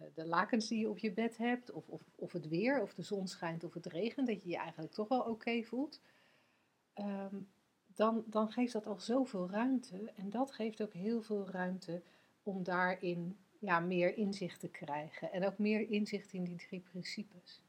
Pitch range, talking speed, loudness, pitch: 180-220 Hz, 200 wpm, -39 LUFS, 195 Hz